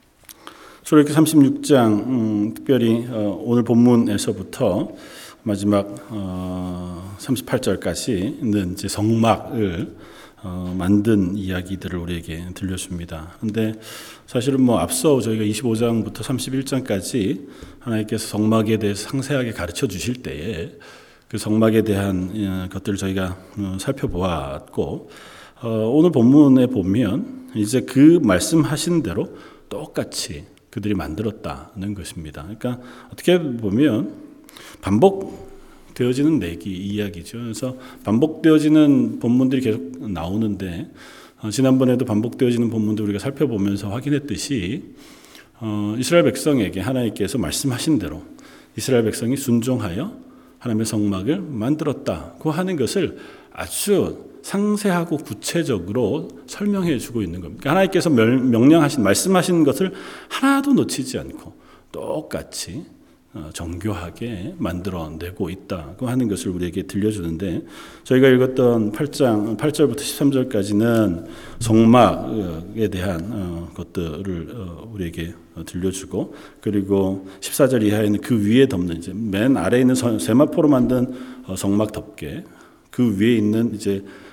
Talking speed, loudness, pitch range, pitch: 280 characters per minute, -20 LUFS, 95-130 Hz, 110 Hz